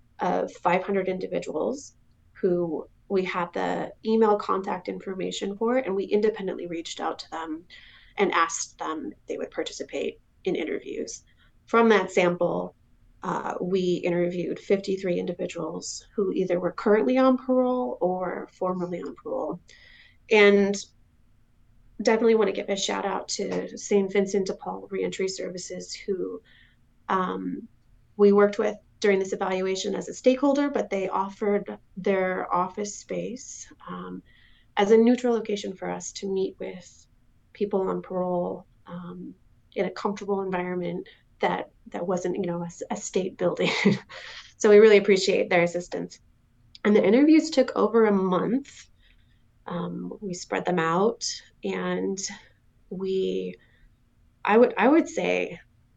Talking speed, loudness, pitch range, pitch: 140 wpm, -25 LUFS, 175-215 Hz, 195 Hz